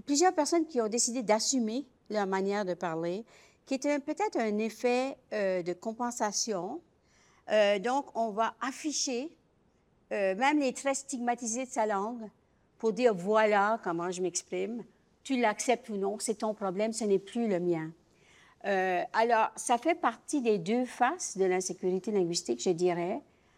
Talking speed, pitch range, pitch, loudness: 160 wpm, 195-255 Hz, 220 Hz, -31 LUFS